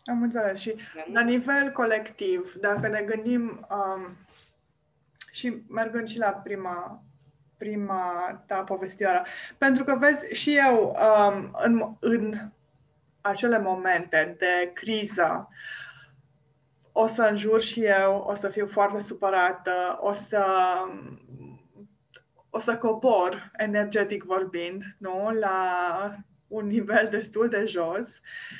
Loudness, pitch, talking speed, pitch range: -26 LUFS, 205 Hz, 115 wpm, 185-220 Hz